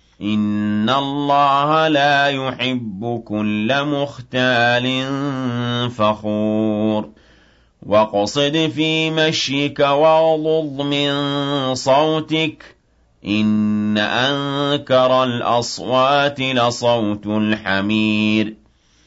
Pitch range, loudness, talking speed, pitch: 105-140 Hz, -17 LUFS, 55 wpm, 125 Hz